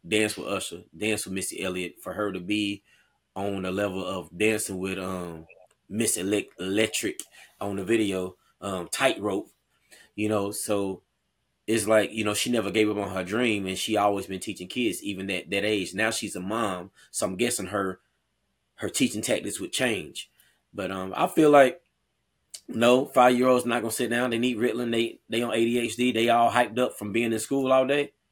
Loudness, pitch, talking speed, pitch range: -26 LUFS, 105 Hz, 195 wpm, 95-115 Hz